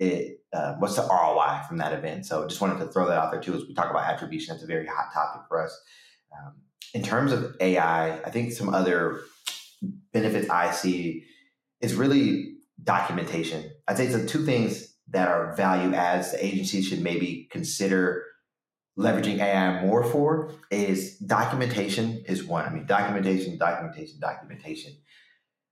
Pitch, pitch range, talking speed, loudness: 95 Hz, 90-115 Hz, 170 wpm, -26 LUFS